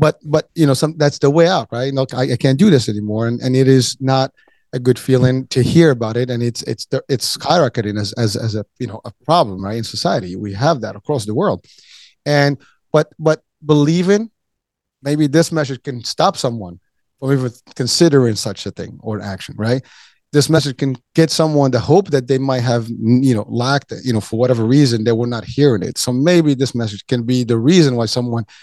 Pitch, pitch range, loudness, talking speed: 130 Hz, 115-145 Hz, -16 LUFS, 220 wpm